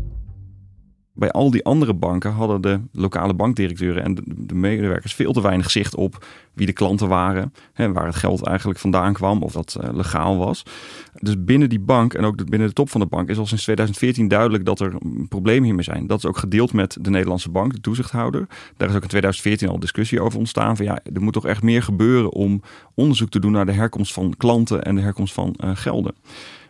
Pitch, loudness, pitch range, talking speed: 100 Hz, -20 LUFS, 95-115 Hz, 215 wpm